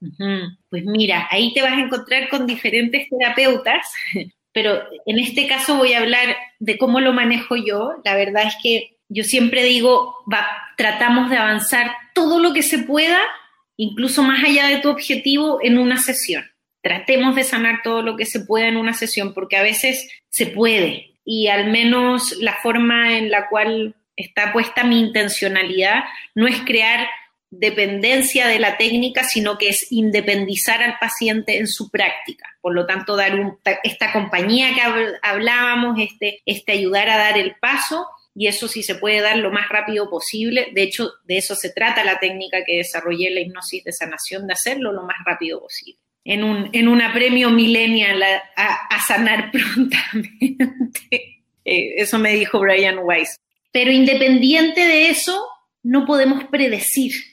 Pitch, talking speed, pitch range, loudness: 230 Hz, 165 wpm, 205-255 Hz, -17 LUFS